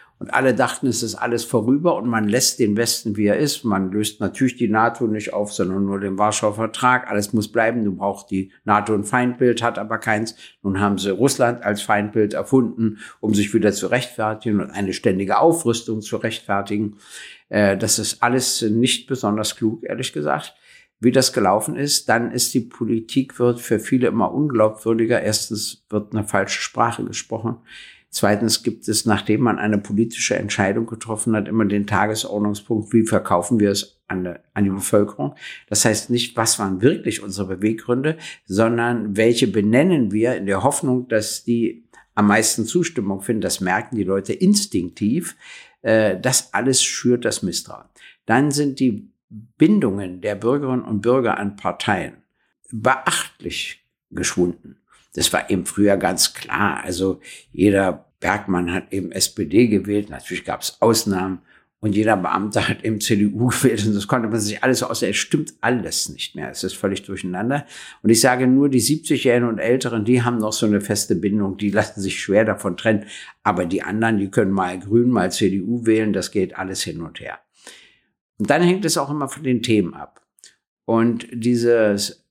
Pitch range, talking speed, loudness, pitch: 100-120 Hz, 175 wpm, -20 LUFS, 110 Hz